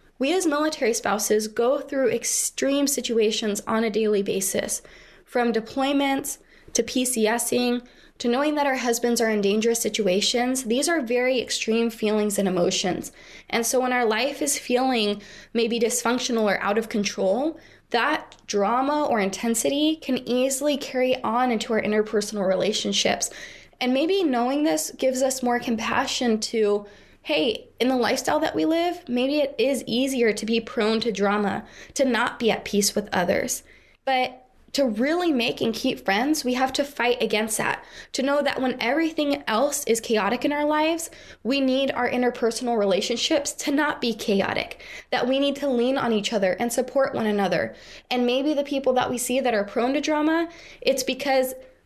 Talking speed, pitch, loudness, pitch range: 170 wpm, 245 Hz, -23 LUFS, 220-270 Hz